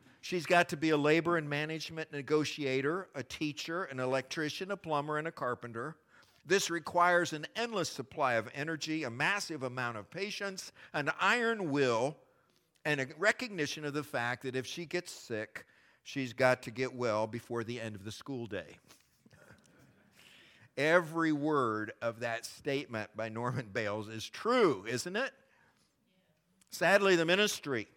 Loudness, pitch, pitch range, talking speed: -33 LUFS, 150 Hz, 125-175 Hz, 150 wpm